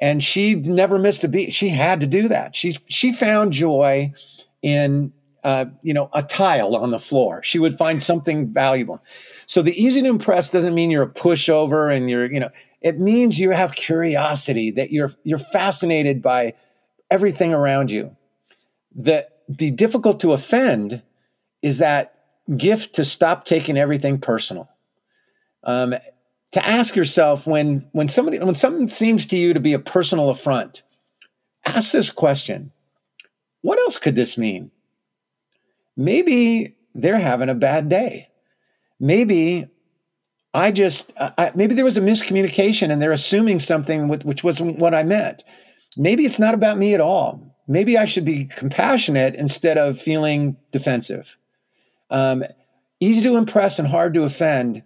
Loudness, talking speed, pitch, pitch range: -18 LUFS, 160 wpm, 165 Hz, 140-195 Hz